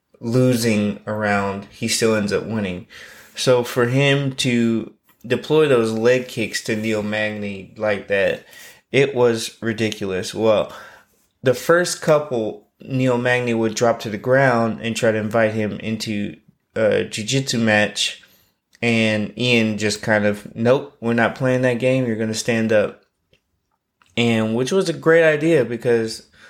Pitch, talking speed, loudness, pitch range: 115 Hz, 145 wpm, -19 LUFS, 105-125 Hz